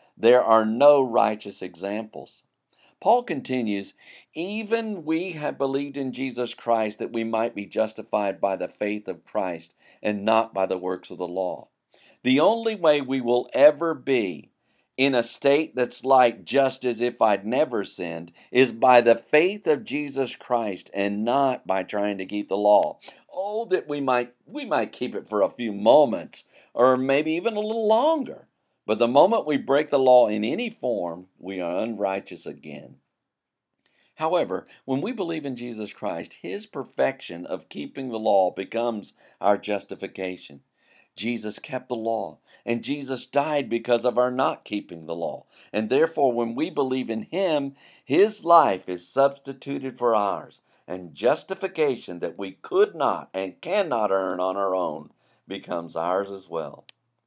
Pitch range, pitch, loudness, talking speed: 105-145 Hz, 125 Hz, -24 LUFS, 165 wpm